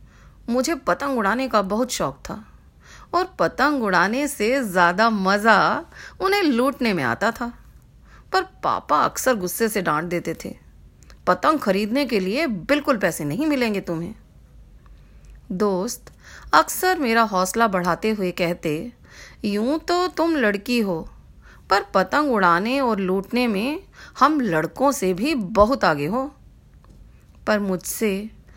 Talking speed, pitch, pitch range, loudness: 130 wpm, 225 Hz, 190-275 Hz, -21 LUFS